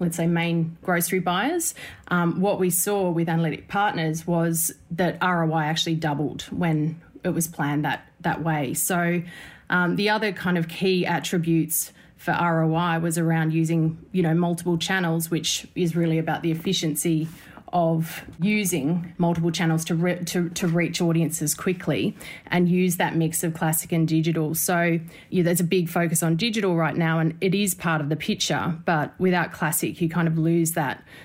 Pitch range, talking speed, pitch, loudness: 160-175 Hz, 175 wpm, 170 Hz, -24 LUFS